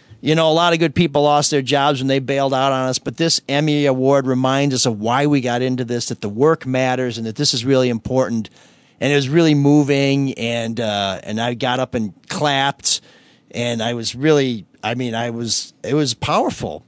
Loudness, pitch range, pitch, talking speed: -18 LUFS, 120-145 Hz, 130 Hz, 220 wpm